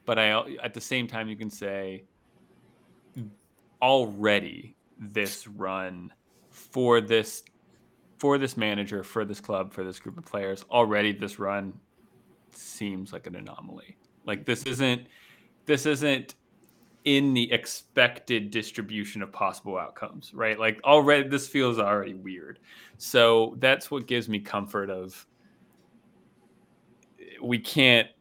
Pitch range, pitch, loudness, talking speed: 100-125 Hz, 110 Hz, -26 LUFS, 130 wpm